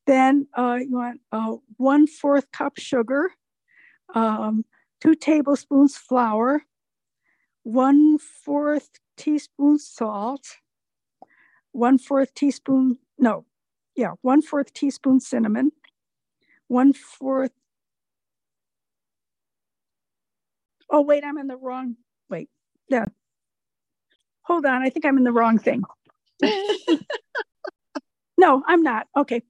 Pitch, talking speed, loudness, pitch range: 270 Hz, 100 wpm, -21 LUFS, 245-295 Hz